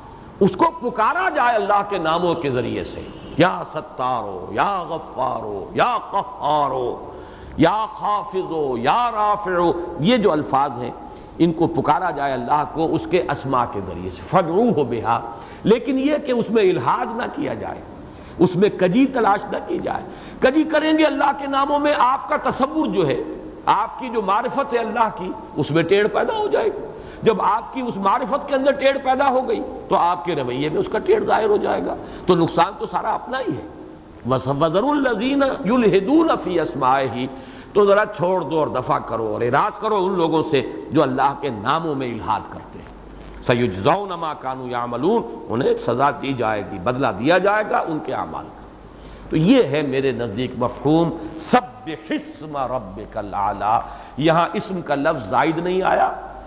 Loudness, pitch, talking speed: -20 LUFS, 195 Hz, 175 wpm